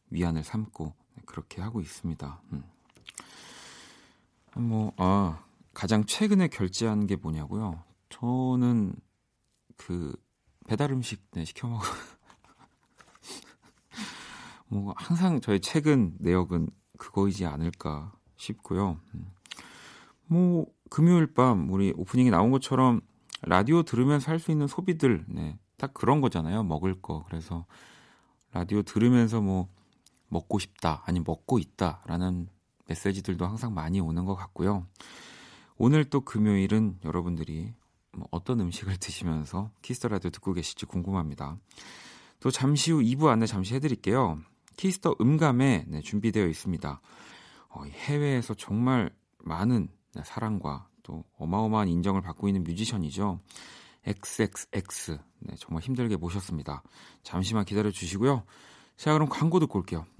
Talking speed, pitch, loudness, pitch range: 270 characters per minute, 100 Hz, -28 LUFS, 85-125 Hz